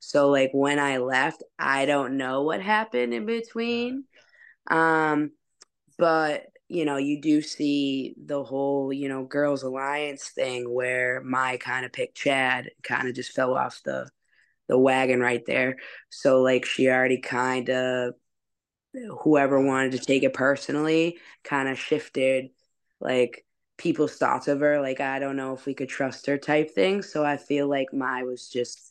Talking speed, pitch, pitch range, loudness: 165 wpm, 140 Hz, 130-150 Hz, -25 LUFS